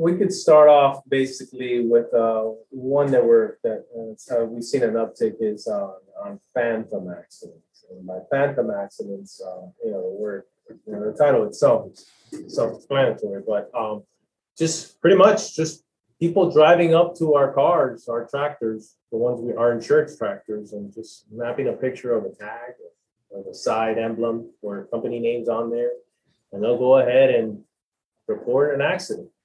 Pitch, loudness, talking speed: 135 Hz, -21 LUFS, 170 wpm